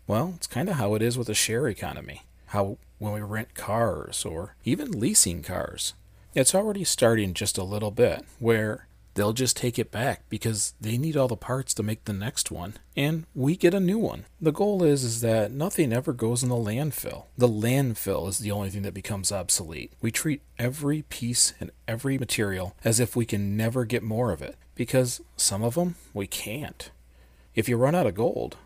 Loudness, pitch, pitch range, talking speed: -26 LUFS, 115 Hz, 100-130 Hz, 205 wpm